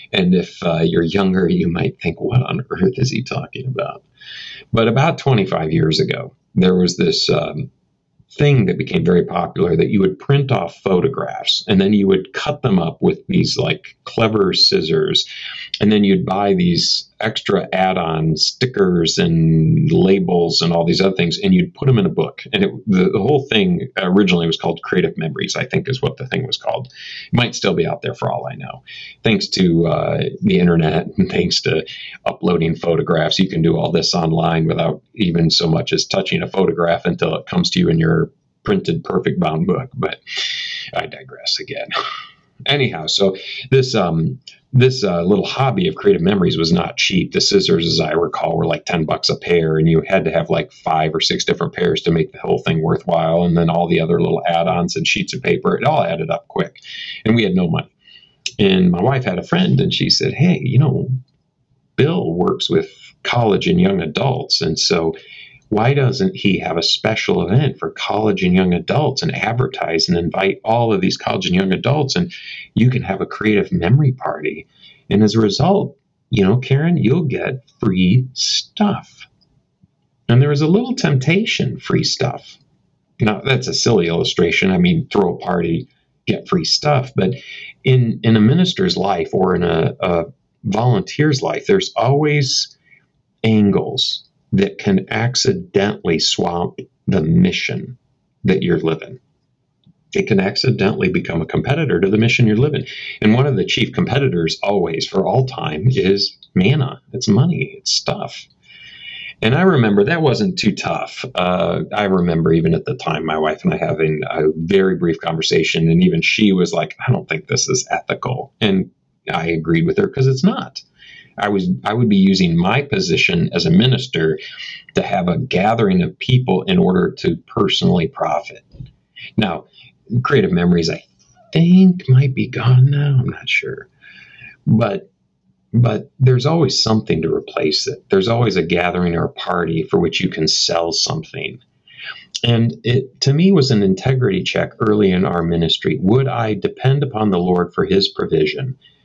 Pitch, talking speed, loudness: 130 Hz, 185 wpm, -16 LUFS